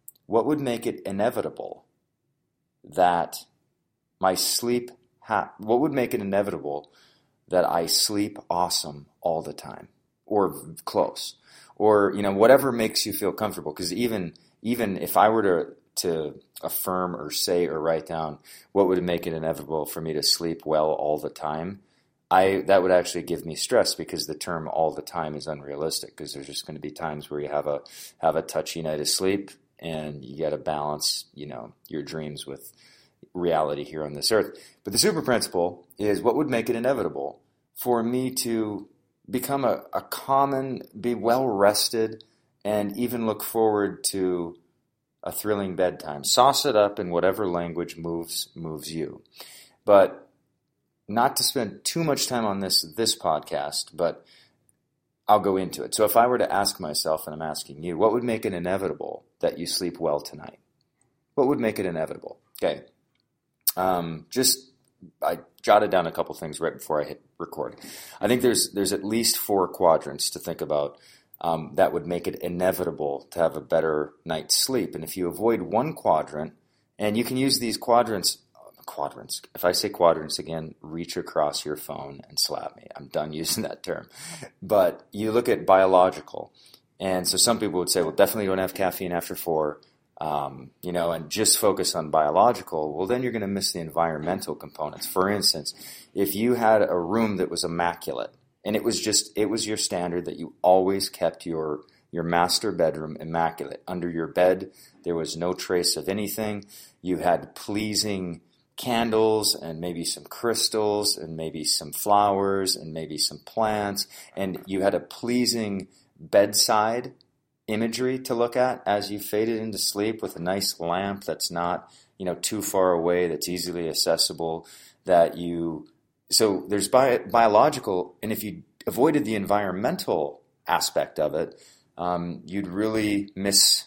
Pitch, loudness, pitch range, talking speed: 95 Hz, -25 LUFS, 80-110 Hz, 175 wpm